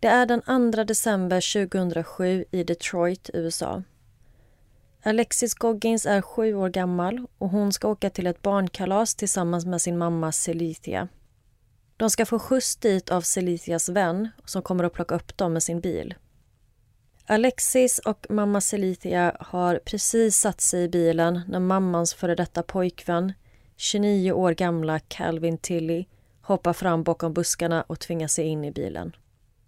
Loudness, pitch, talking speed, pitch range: -24 LUFS, 180 Hz, 150 wpm, 165-205 Hz